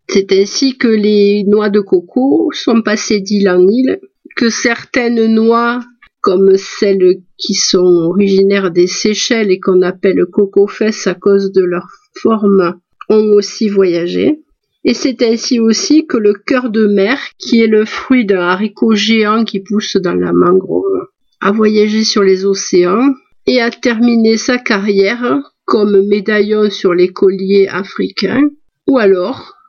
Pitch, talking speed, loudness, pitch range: 210 Hz, 150 wpm, -12 LUFS, 195-240 Hz